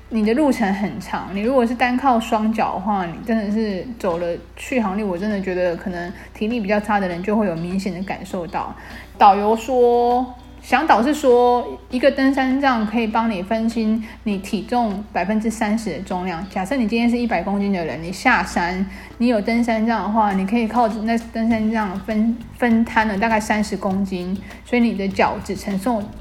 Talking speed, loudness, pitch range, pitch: 285 characters per minute, -20 LUFS, 200-235 Hz, 220 Hz